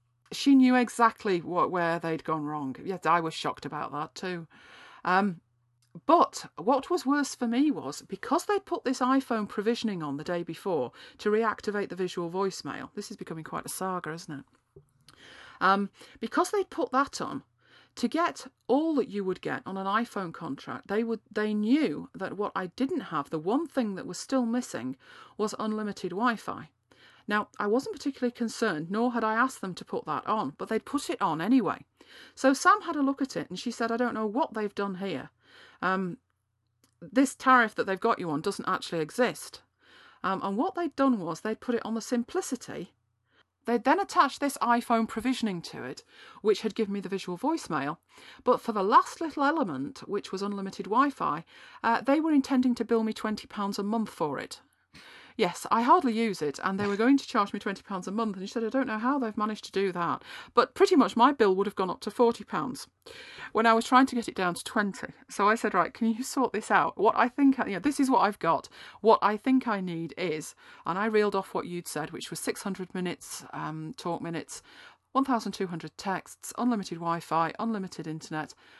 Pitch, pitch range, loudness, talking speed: 220 Hz, 190-260 Hz, -29 LUFS, 215 wpm